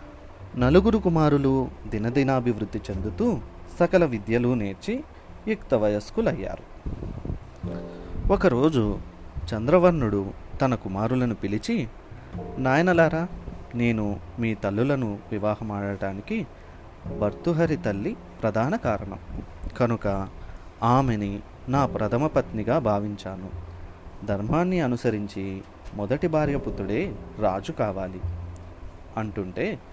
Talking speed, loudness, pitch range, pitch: 70 wpm, -25 LUFS, 95-130 Hz, 105 Hz